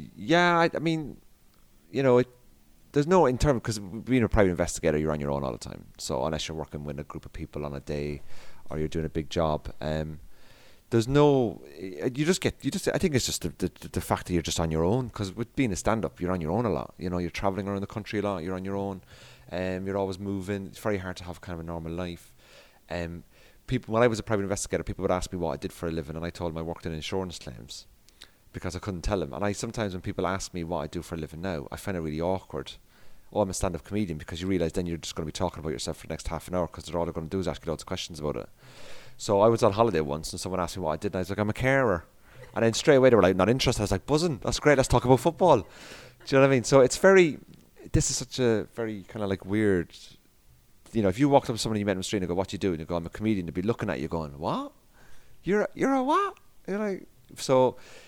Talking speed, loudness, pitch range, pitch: 295 wpm, -27 LUFS, 85-115 Hz, 95 Hz